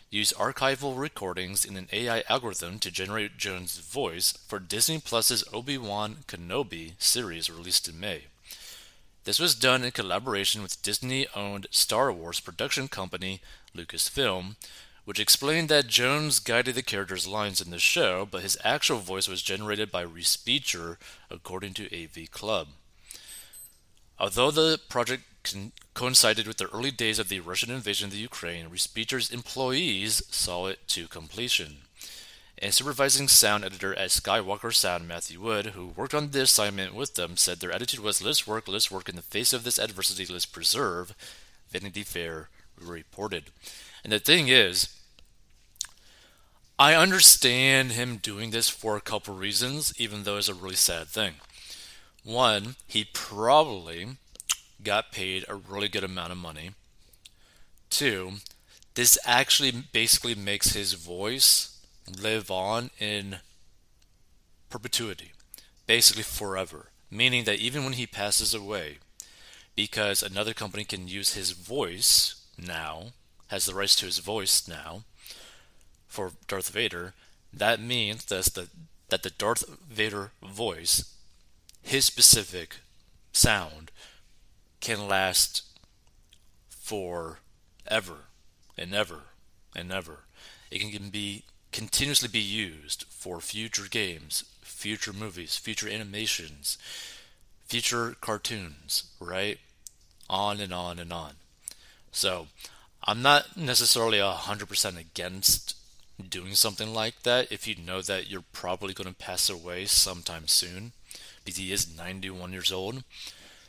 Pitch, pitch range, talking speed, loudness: 100 Hz, 90-115 Hz, 135 wpm, -25 LUFS